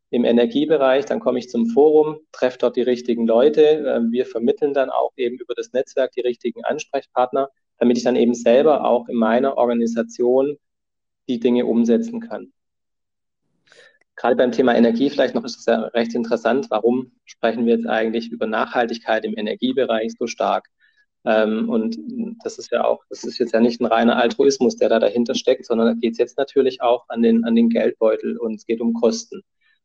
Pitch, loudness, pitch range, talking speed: 120 Hz, -19 LUFS, 115-150 Hz, 185 wpm